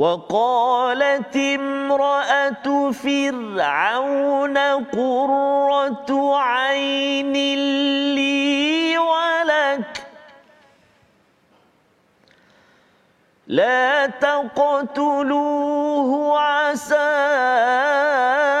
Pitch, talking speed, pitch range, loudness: 280 Hz, 30 wpm, 275-285 Hz, -19 LUFS